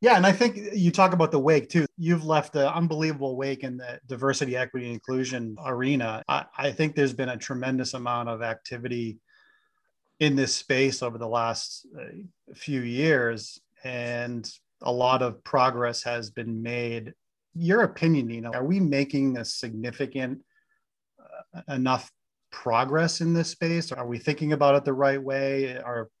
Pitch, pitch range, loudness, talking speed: 135 Hz, 120-155 Hz, -26 LUFS, 165 wpm